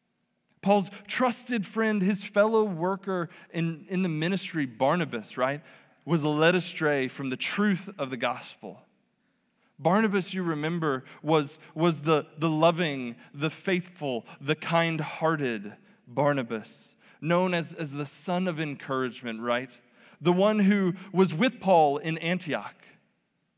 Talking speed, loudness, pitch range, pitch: 130 wpm, -27 LUFS, 145-190 Hz, 165 Hz